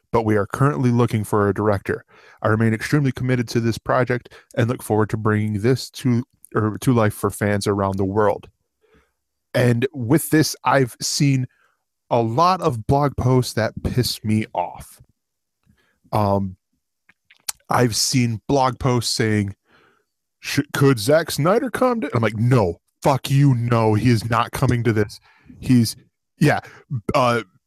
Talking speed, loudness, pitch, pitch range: 150 wpm, -20 LUFS, 120 Hz, 110-135 Hz